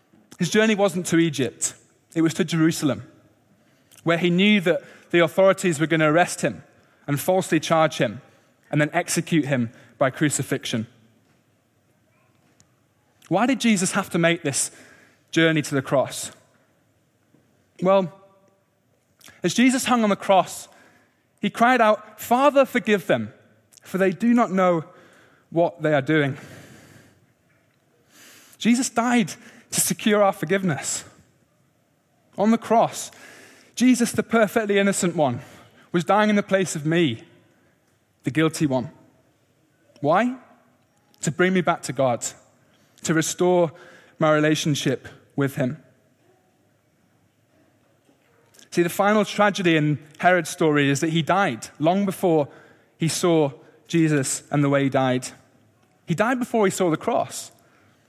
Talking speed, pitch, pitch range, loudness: 130 wpm, 165 Hz, 140-195 Hz, -22 LUFS